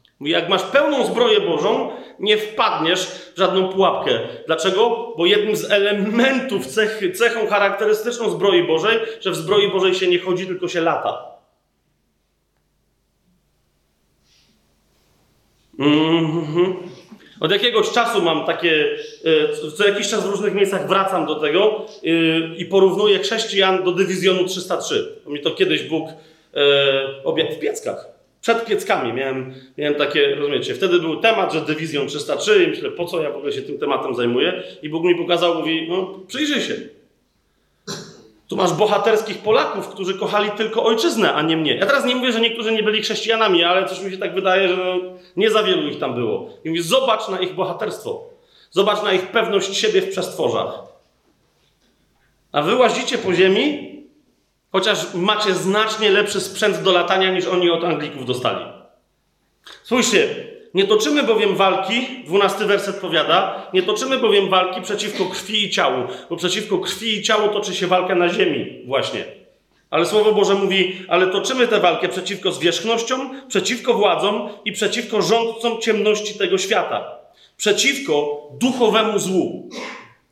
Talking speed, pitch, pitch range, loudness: 150 wpm, 200 Hz, 180-230 Hz, -18 LUFS